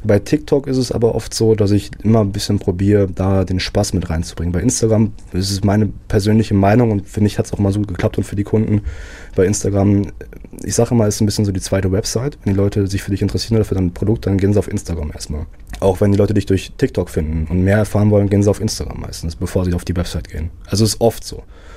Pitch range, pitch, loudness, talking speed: 90-110 Hz, 100 Hz, -17 LUFS, 260 wpm